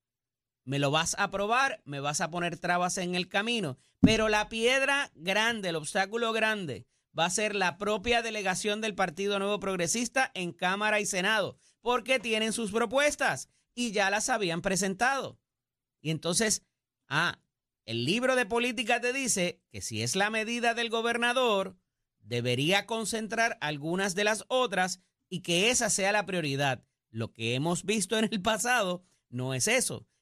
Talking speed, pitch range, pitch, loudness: 160 wpm, 165-225 Hz, 200 Hz, -29 LUFS